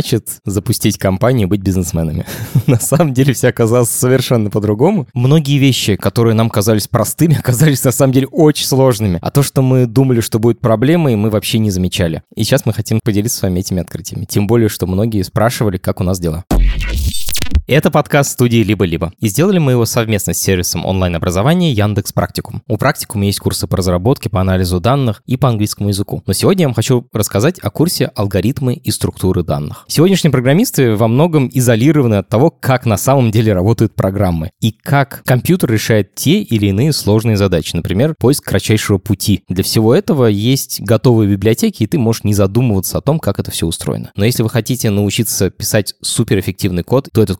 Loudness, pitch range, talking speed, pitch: -14 LUFS, 100-130 Hz, 185 wpm, 110 Hz